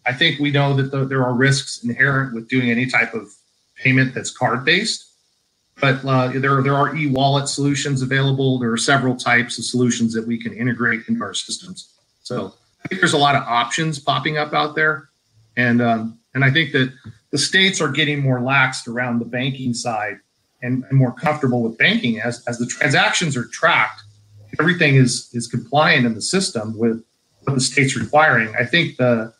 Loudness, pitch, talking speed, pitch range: -18 LUFS, 130 Hz, 190 wpm, 120-140 Hz